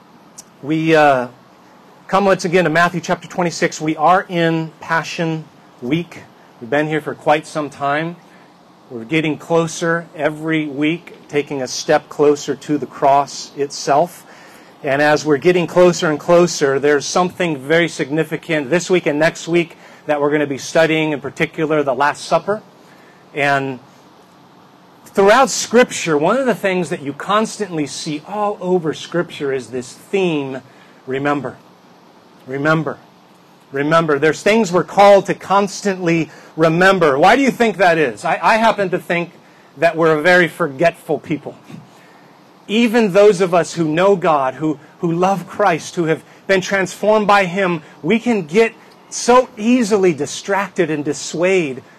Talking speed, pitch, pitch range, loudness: 150 wpm, 165 Hz, 150-190 Hz, -16 LUFS